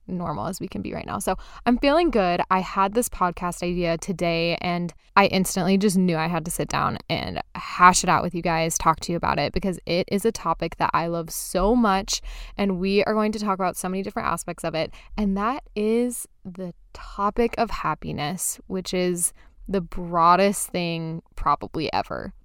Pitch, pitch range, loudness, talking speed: 185 Hz, 170-205 Hz, -23 LUFS, 205 wpm